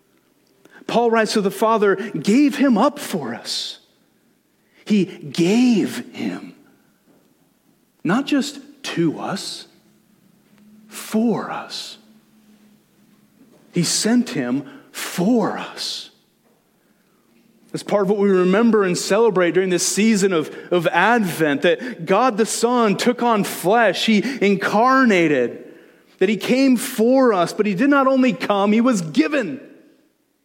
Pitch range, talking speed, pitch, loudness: 200-255 Hz, 120 wpm, 220 Hz, -18 LUFS